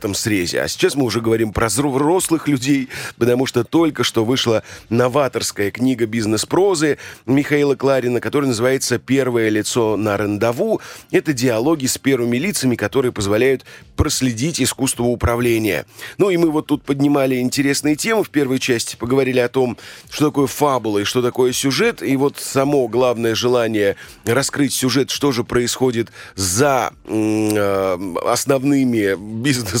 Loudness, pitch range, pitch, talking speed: -18 LUFS, 115-140 Hz, 125 Hz, 140 wpm